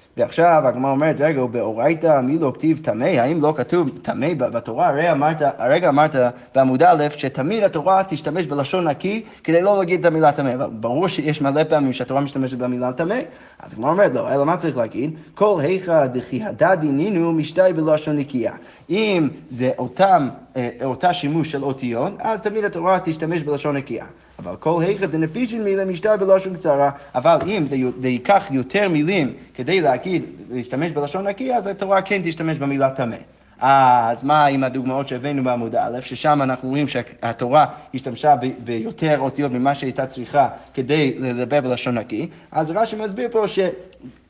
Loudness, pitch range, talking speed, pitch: -19 LUFS, 130-180 Hz, 160 wpm, 150 Hz